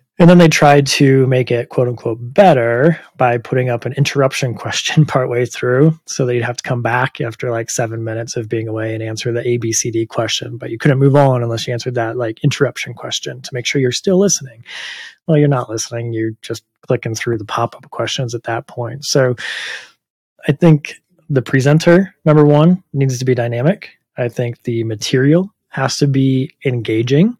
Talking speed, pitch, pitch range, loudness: 195 wpm, 125 Hz, 115-145 Hz, -15 LUFS